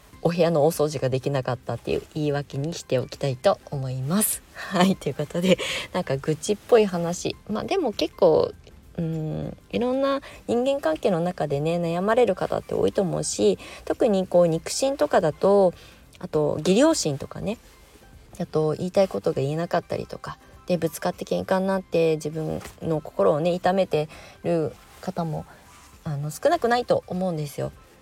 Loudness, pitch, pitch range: -24 LUFS, 170 Hz, 150-190 Hz